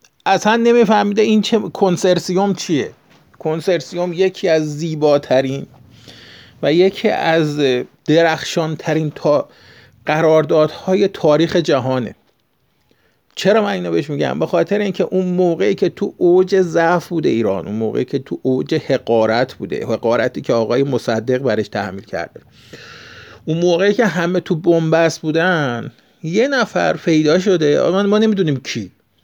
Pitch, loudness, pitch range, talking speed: 165 Hz, -16 LUFS, 145-185 Hz, 125 wpm